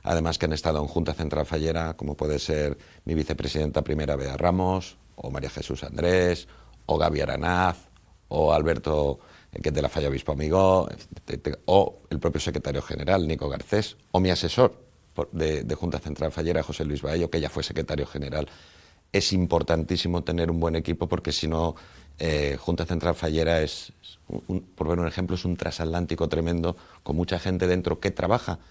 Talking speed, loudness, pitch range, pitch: 180 wpm, -26 LUFS, 75-90 Hz, 80 Hz